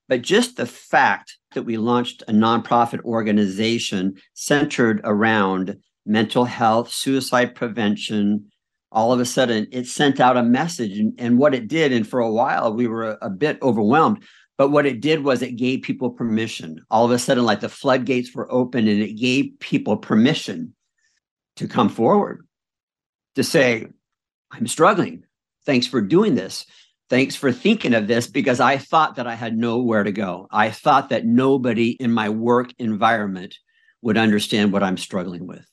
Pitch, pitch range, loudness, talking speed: 120 Hz, 110-130 Hz, -20 LUFS, 170 wpm